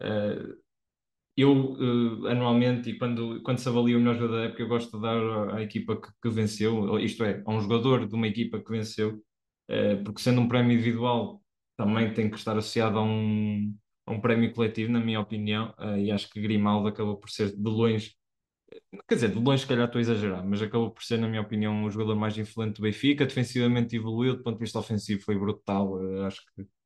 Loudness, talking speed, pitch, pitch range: -28 LUFS, 220 wpm, 110 Hz, 105-120 Hz